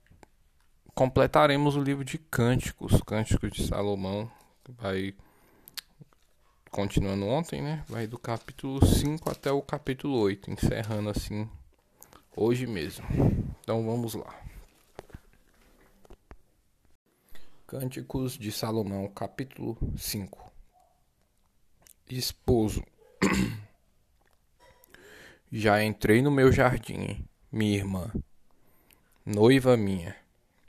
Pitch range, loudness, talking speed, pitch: 100-130 Hz, -28 LUFS, 85 wpm, 110 Hz